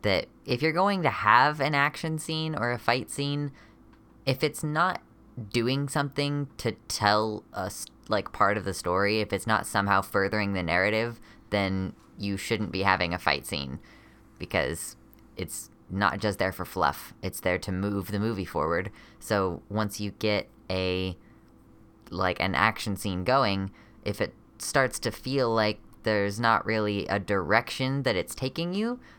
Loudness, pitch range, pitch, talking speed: -28 LUFS, 95-130 Hz, 110 Hz, 165 wpm